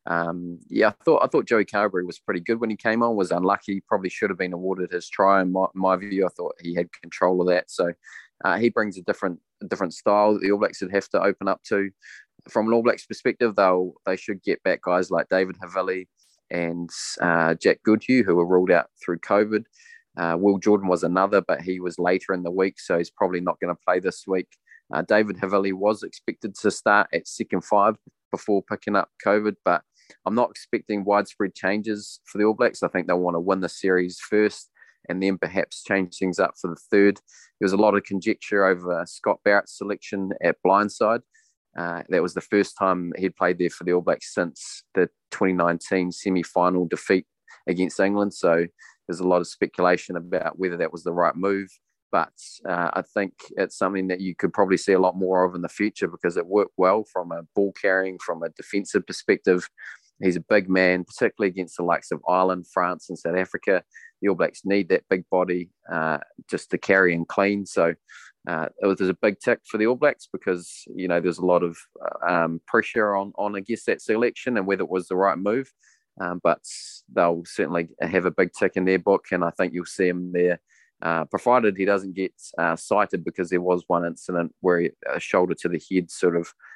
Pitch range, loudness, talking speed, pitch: 90-100 Hz, -24 LUFS, 220 wpm, 95 Hz